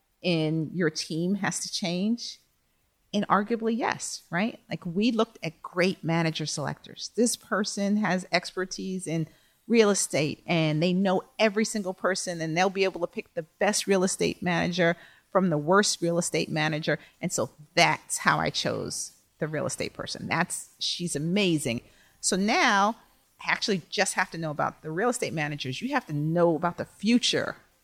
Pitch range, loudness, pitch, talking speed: 160-205 Hz, -27 LUFS, 180 Hz, 170 wpm